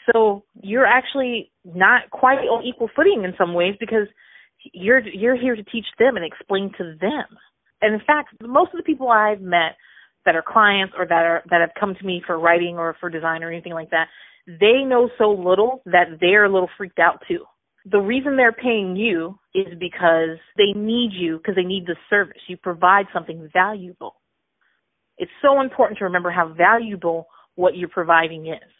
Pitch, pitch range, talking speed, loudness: 195 Hz, 175-230 Hz, 190 wpm, -19 LUFS